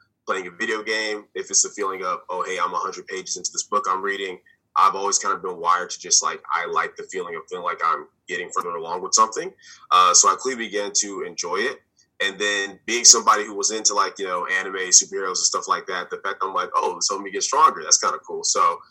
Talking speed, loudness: 255 wpm, -20 LUFS